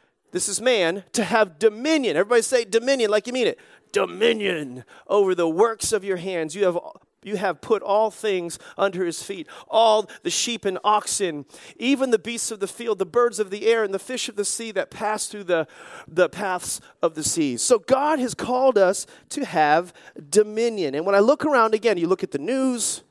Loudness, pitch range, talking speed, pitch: -22 LUFS, 185-235 Hz, 210 wpm, 210 Hz